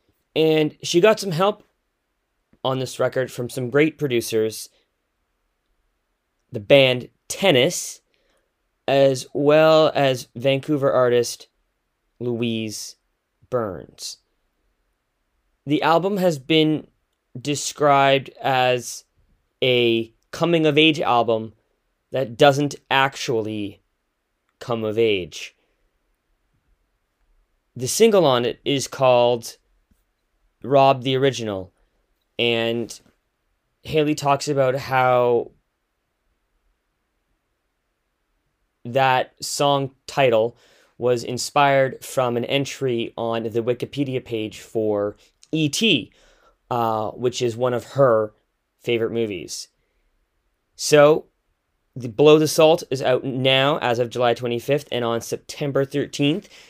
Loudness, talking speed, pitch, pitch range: -20 LUFS, 95 wpm, 125 Hz, 115-145 Hz